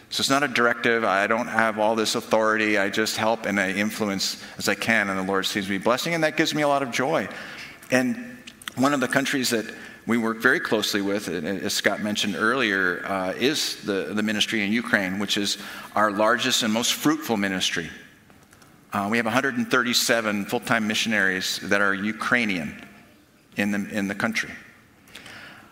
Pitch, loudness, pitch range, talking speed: 110 Hz, -23 LUFS, 100-125 Hz, 185 wpm